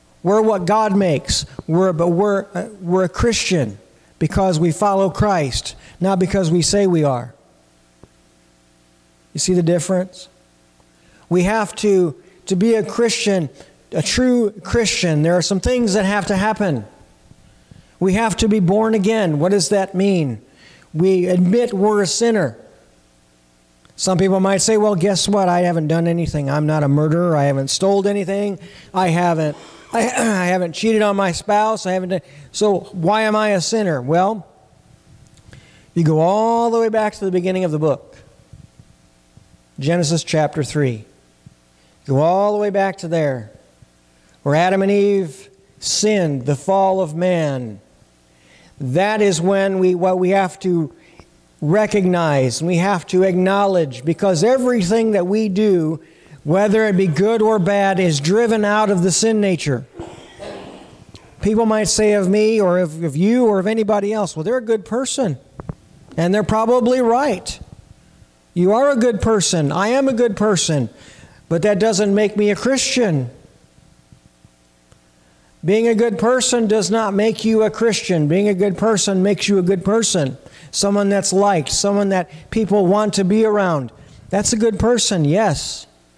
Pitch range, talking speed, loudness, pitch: 155-210 Hz, 160 wpm, -17 LUFS, 190 Hz